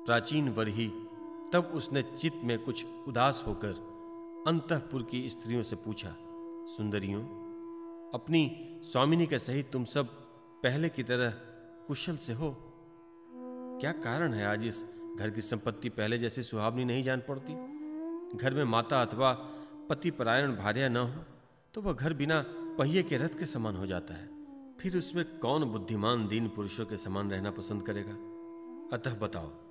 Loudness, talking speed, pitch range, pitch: -33 LUFS, 150 wpm, 115-170 Hz, 135 Hz